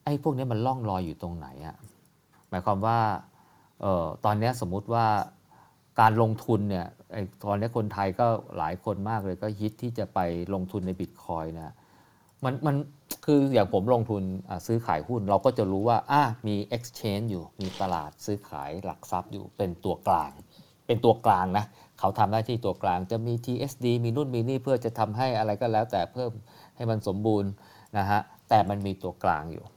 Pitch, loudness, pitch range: 105 Hz, -28 LUFS, 95-120 Hz